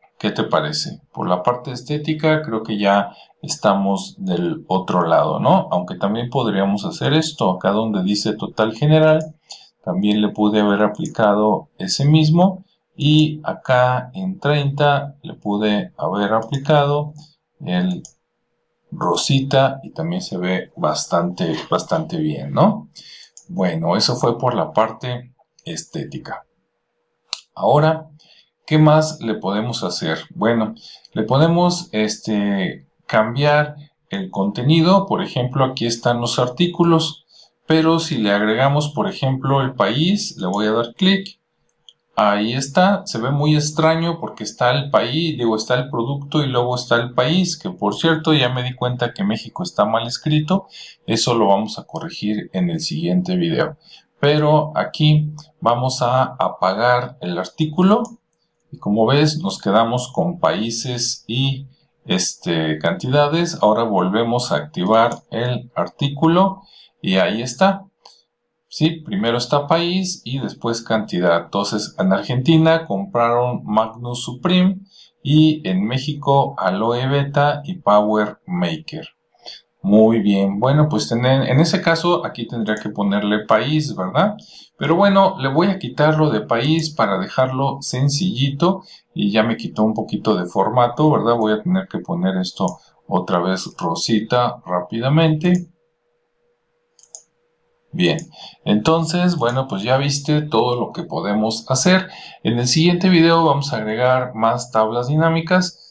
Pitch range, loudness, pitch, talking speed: 115-160 Hz, -18 LUFS, 140 Hz, 135 wpm